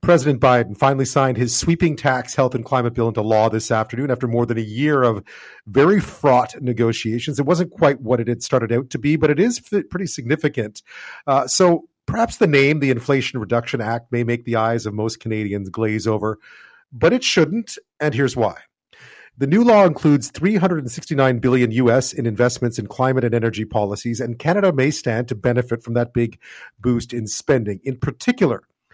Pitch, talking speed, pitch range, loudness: 125 Hz, 190 wpm, 115-150 Hz, -19 LUFS